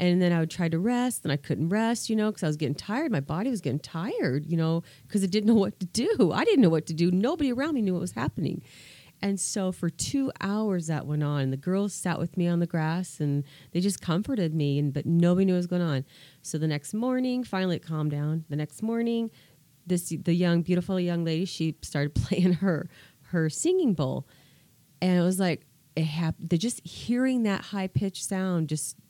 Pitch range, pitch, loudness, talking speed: 155-200 Hz, 175 Hz, -27 LUFS, 230 wpm